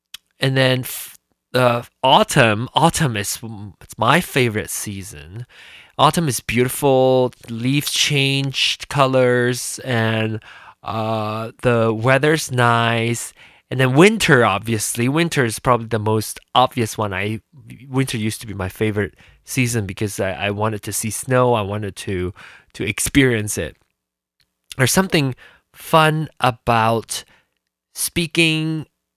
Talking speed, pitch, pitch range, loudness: 125 wpm, 120 Hz, 105-135 Hz, -18 LUFS